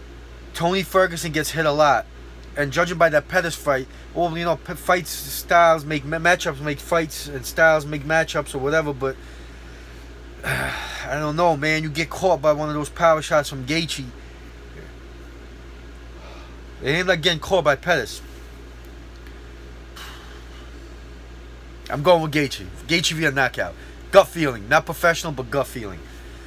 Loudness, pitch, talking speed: -21 LUFS, 140 Hz, 150 wpm